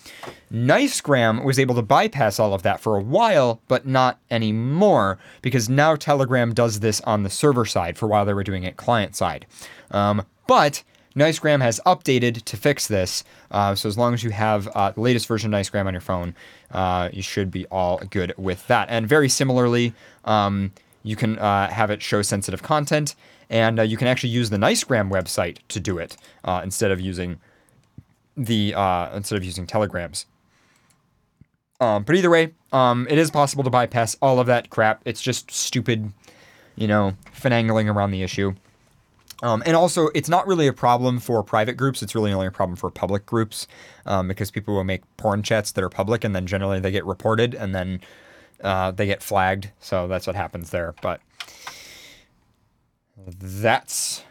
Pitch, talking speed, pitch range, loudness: 110 Hz, 185 wpm, 100-125 Hz, -21 LUFS